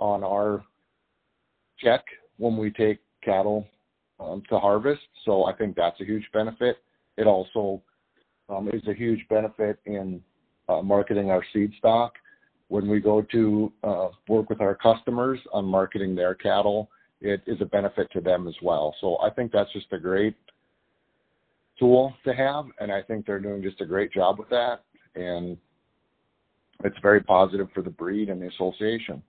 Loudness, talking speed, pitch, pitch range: -25 LUFS, 170 wpm, 105 Hz, 95-110 Hz